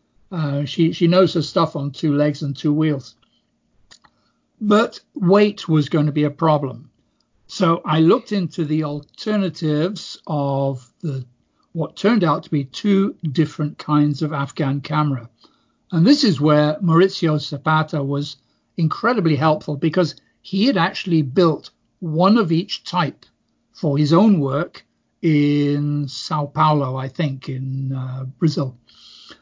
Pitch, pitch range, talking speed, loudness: 155 Hz, 145-175 Hz, 140 wpm, -19 LUFS